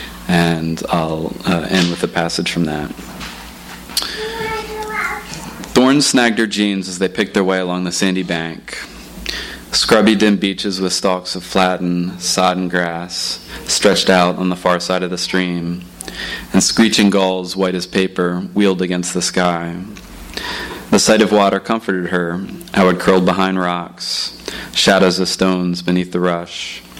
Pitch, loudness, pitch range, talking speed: 90 Hz, -16 LUFS, 90-95 Hz, 150 wpm